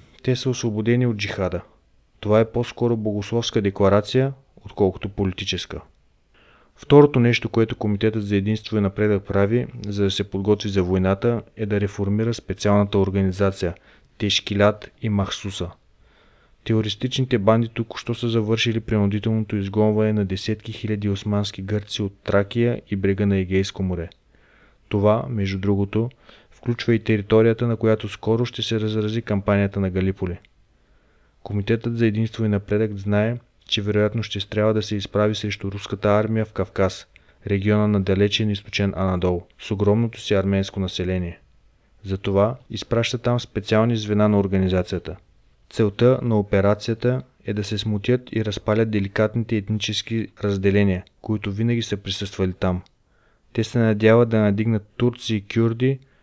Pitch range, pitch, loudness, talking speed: 100-115 Hz, 105 Hz, -22 LUFS, 140 wpm